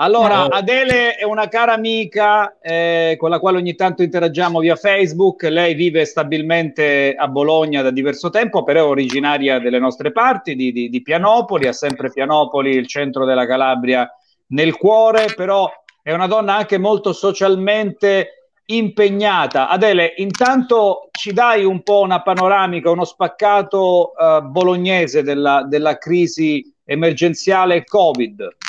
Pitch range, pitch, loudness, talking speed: 150-205 Hz, 180 Hz, -15 LUFS, 140 wpm